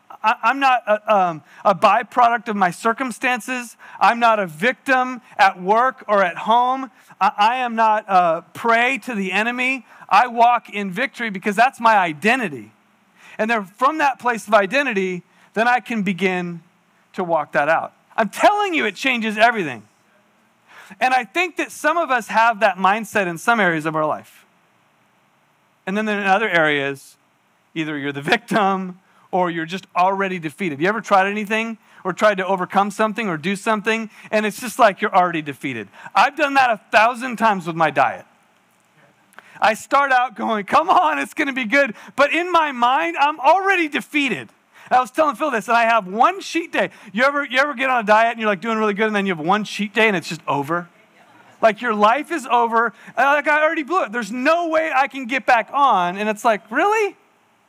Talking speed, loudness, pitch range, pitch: 200 wpm, -18 LUFS, 195-260 Hz, 225 Hz